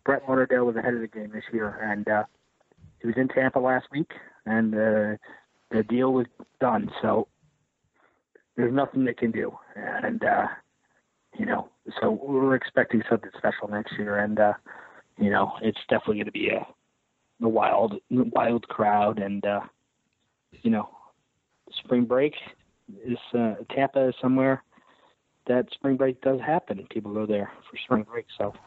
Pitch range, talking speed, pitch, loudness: 105-130 Hz, 160 wpm, 120 Hz, -26 LUFS